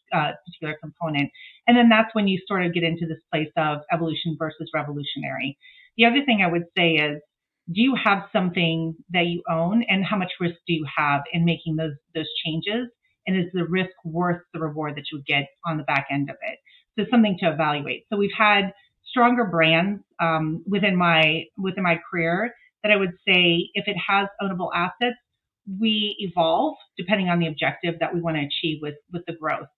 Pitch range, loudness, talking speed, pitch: 160-200 Hz, -23 LUFS, 200 wpm, 175 Hz